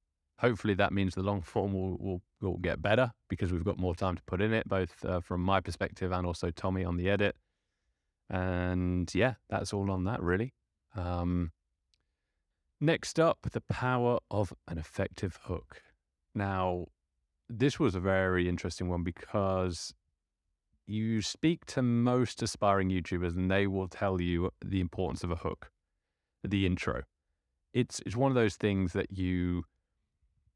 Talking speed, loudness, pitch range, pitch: 160 wpm, -32 LUFS, 85-100 Hz, 95 Hz